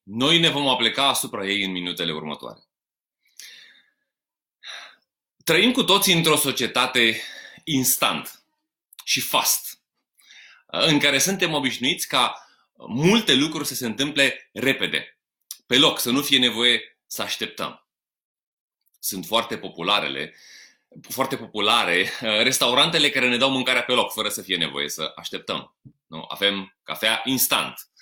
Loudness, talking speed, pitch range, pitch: -20 LUFS, 125 wpm, 110-145 Hz, 130 Hz